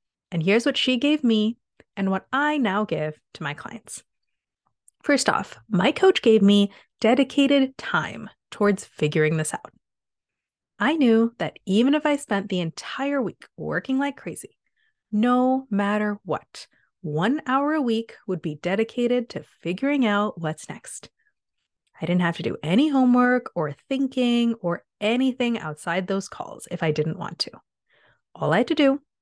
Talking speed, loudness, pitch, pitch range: 160 wpm, -23 LUFS, 225 Hz, 185-265 Hz